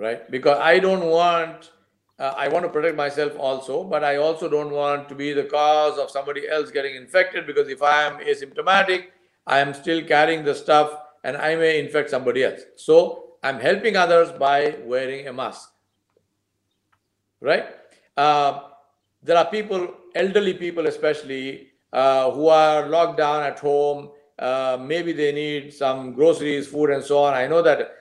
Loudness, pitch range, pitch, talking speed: -21 LUFS, 140-170 Hz, 150 Hz, 170 wpm